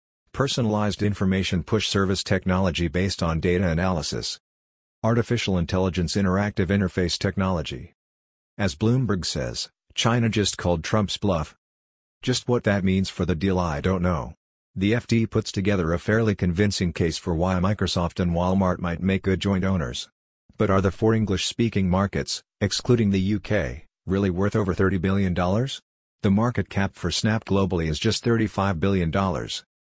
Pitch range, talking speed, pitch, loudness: 90-105 Hz, 150 wpm, 95 Hz, -24 LUFS